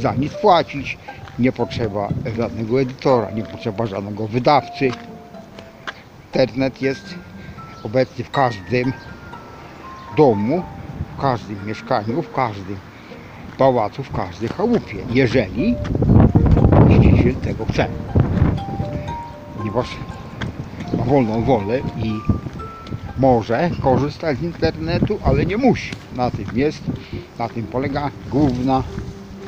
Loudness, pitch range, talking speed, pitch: -19 LUFS, 105-135 Hz, 100 wpm, 120 Hz